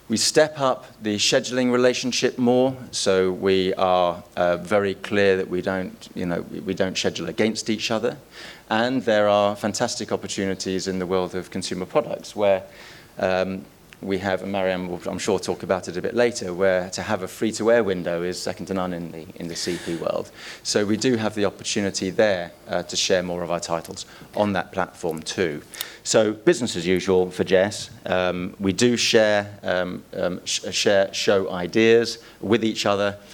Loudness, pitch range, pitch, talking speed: -23 LUFS, 90-110 Hz, 100 Hz, 185 wpm